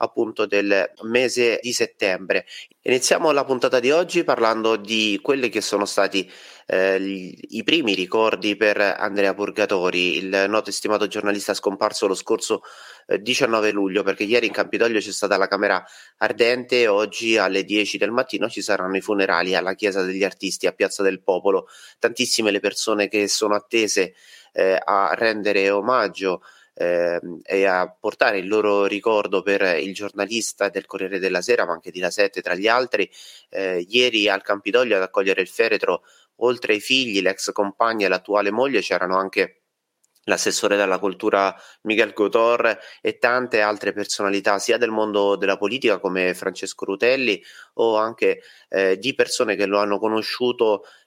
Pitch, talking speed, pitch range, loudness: 100 Hz, 160 wpm, 95-115 Hz, -21 LUFS